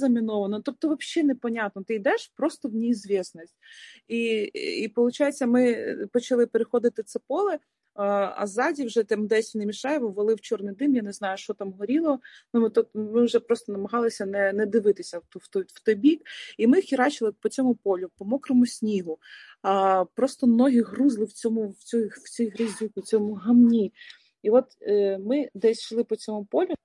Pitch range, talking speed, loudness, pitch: 210-255 Hz, 185 wpm, -25 LUFS, 230 Hz